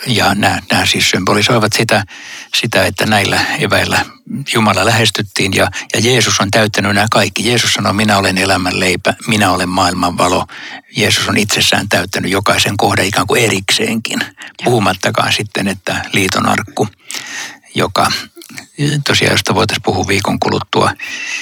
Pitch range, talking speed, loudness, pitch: 100-115 Hz, 135 wpm, -13 LUFS, 105 Hz